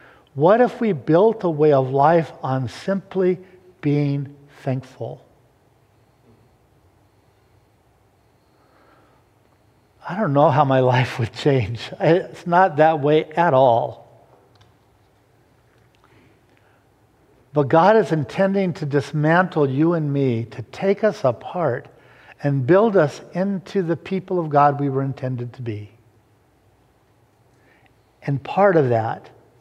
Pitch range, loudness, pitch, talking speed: 115-165 Hz, -19 LUFS, 135 Hz, 115 wpm